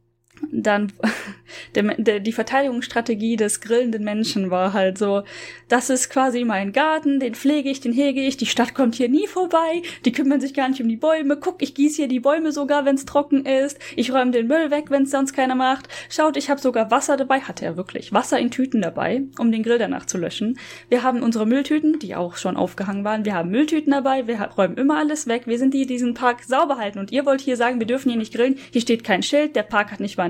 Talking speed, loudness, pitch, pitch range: 240 wpm, -21 LUFS, 255 Hz, 225-280 Hz